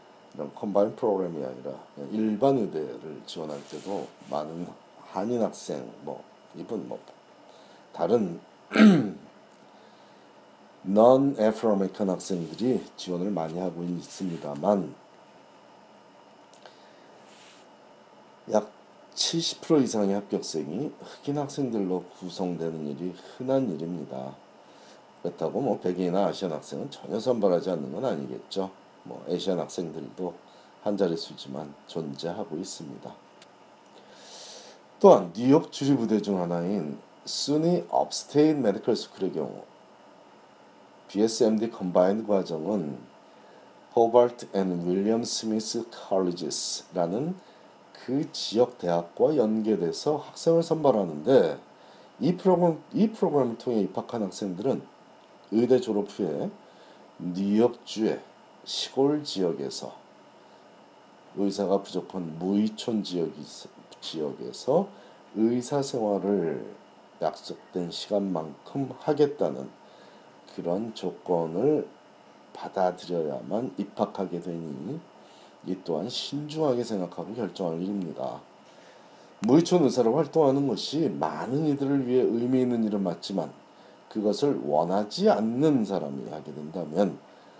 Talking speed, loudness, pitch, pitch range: 260 characters per minute, -27 LUFS, 105 Hz, 90-130 Hz